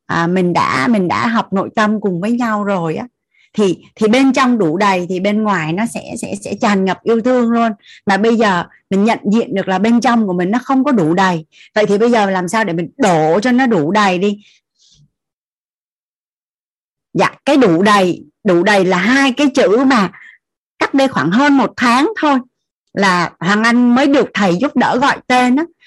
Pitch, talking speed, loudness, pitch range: 215 Hz, 210 wpm, -14 LUFS, 190-250 Hz